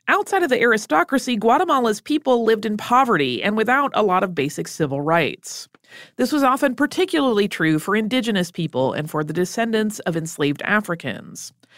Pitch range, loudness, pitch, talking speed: 175-255 Hz, -20 LUFS, 220 Hz, 165 wpm